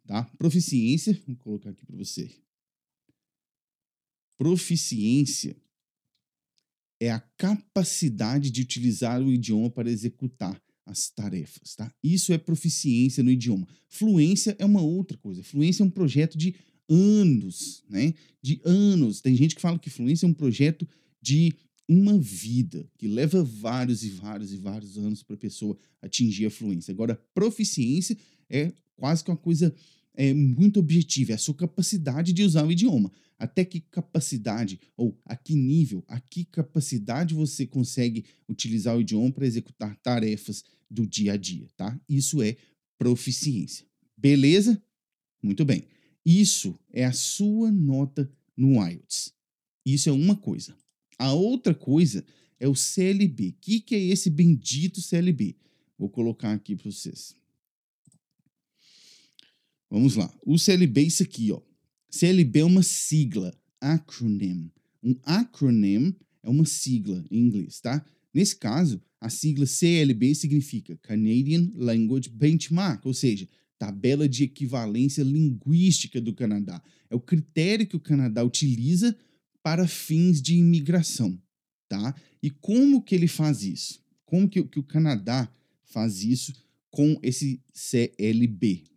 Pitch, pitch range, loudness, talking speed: 145 Hz, 120-170 Hz, -25 LUFS, 140 wpm